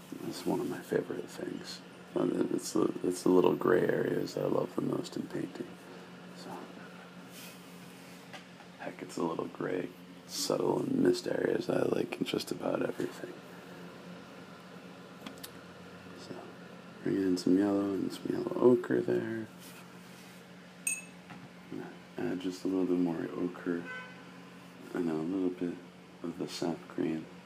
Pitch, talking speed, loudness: 90 Hz, 140 wpm, -33 LUFS